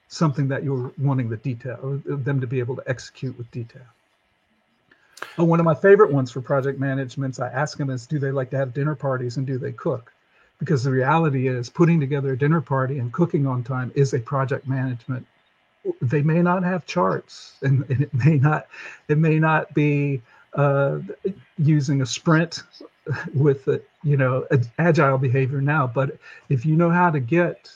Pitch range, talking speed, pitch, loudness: 130-150 Hz, 190 wpm, 140 Hz, -22 LUFS